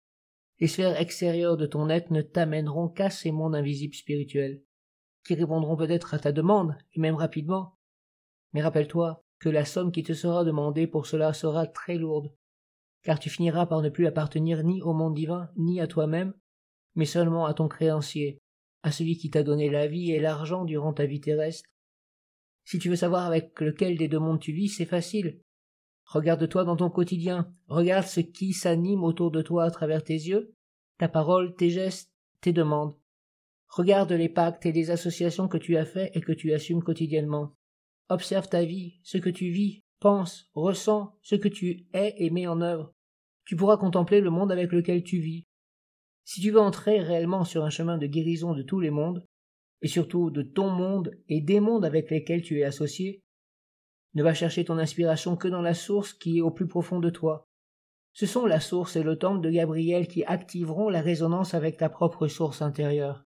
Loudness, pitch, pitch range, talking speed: -27 LUFS, 165 Hz, 155-180 Hz, 195 wpm